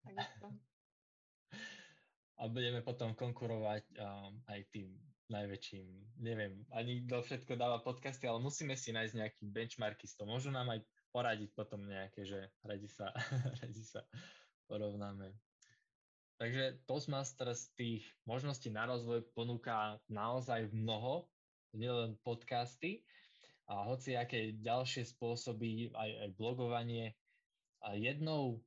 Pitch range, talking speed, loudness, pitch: 105-125 Hz, 115 wpm, -43 LUFS, 115 Hz